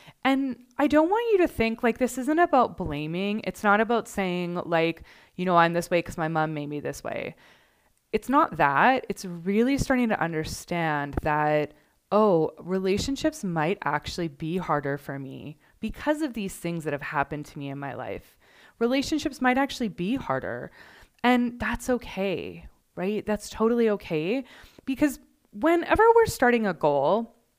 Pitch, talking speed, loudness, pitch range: 200 Hz, 165 wpm, -26 LUFS, 160-255 Hz